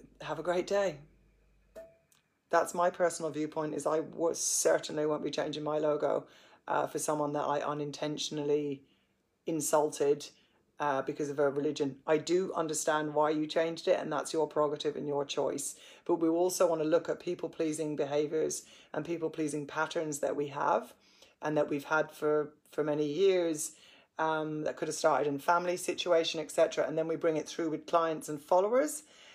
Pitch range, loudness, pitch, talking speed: 150-165 Hz, -32 LUFS, 155 Hz, 175 wpm